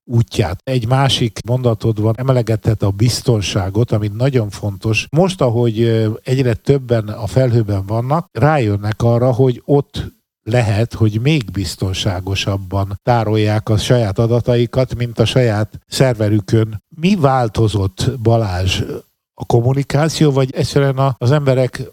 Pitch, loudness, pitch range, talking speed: 120 Hz, -16 LUFS, 110-130 Hz, 120 wpm